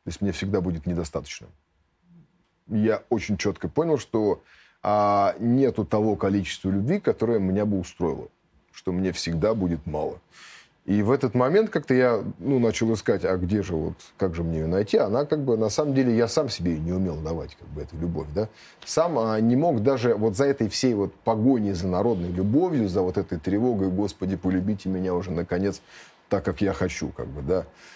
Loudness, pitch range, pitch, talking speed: -25 LUFS, 90-115 Hz, 100 Hz, 195 wpm